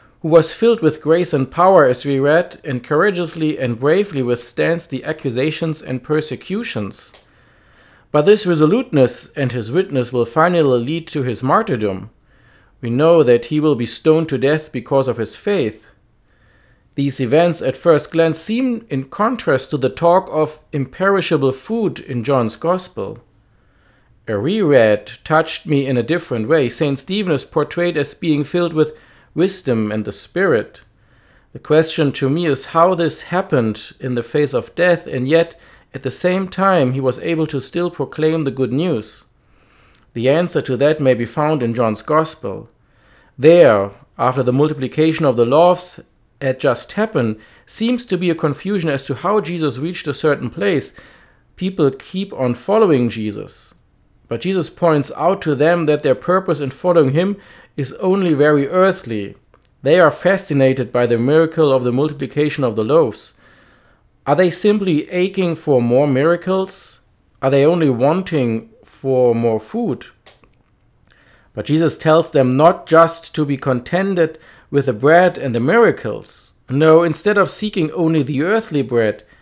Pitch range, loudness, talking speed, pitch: 130-170 Hz, -16 LUFS, 160 wpm, 150 Hz